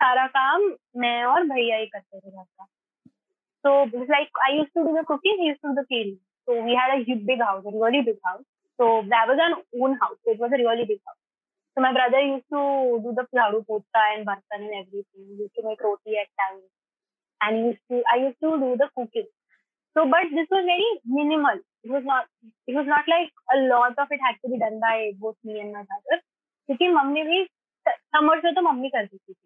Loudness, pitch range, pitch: -23 LUFS, 220-305 Hz, 255 Hz